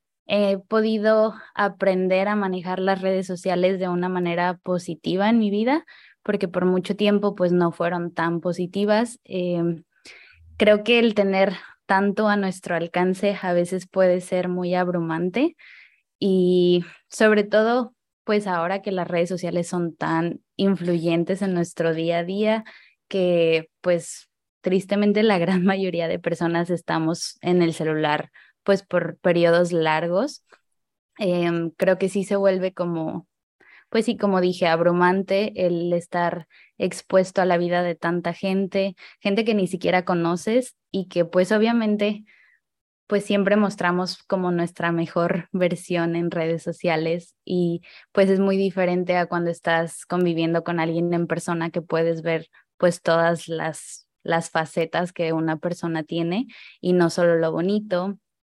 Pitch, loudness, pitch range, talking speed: 180 Hz, -22 LUFS, 170-195 Hz, 145 wpm